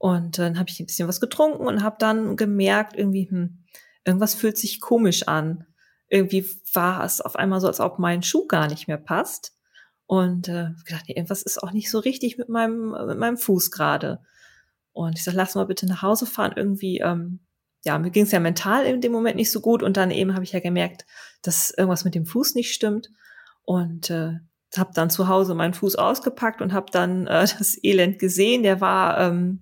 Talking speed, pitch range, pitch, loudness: 215 wpm, 175-215 Hz, 190 Hz, -22 LUFS